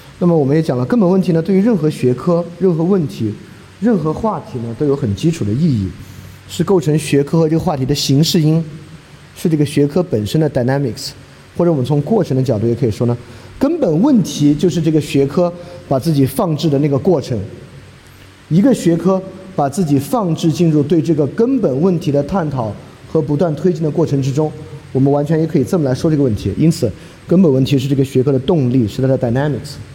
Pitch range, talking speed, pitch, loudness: 130-170 Hz, 345 characters per minute, 150 Hz, -15 LUFS